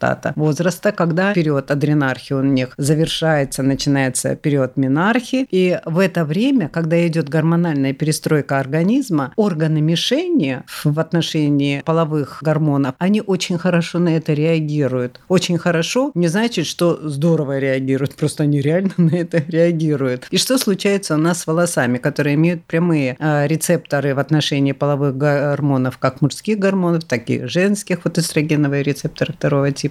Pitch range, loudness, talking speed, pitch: 140-170 Hz, -18 LUFS, 140 wpm, 155 Hz